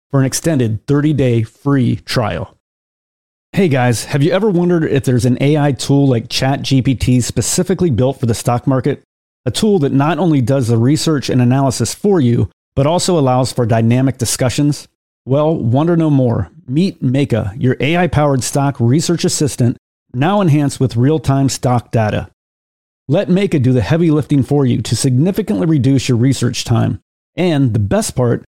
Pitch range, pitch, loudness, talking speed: 120-150 Hz, 135 Hz, -14 LUFS, 165 wpm